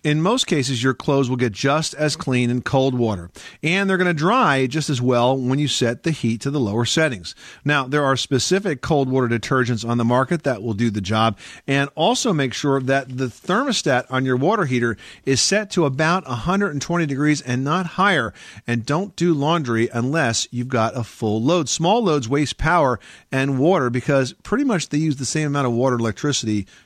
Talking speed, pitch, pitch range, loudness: 210 wpm, 135 Hz, 120-160 Hz, -20 LUFS